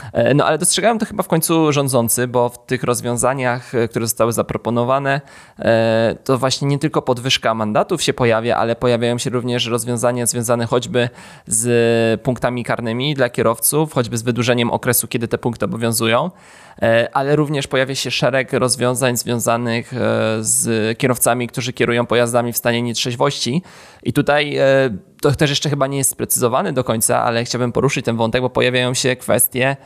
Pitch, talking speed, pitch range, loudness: 125 Hz, 155 wpm, 120-135 Hz, -17 LUFS